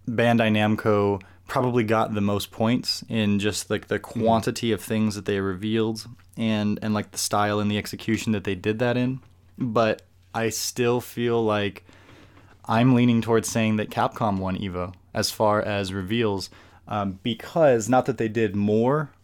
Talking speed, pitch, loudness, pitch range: 170 wpm, 105 Hz, -24 LUFS, 100-115 Hz